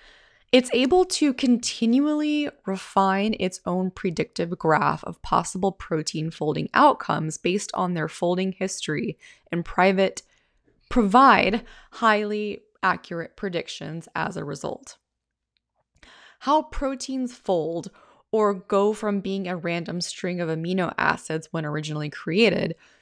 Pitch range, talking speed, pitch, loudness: 170-230 Hz, 115 wpm, 190 Hz, -24 LUFS